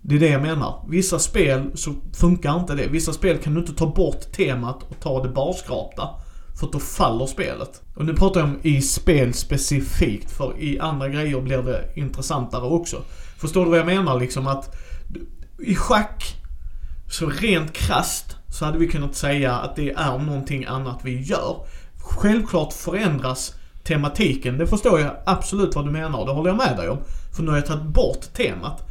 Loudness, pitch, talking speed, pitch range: -22 LUFS, 145 Hz, 190 wpm, 130-165 Hz